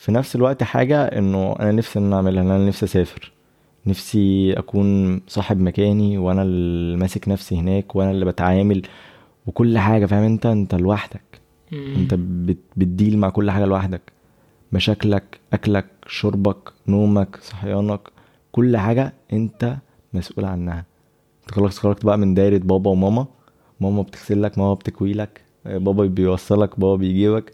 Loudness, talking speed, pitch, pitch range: -20 LUFS, 135 wpm, 100 Hz, 95-105 Hz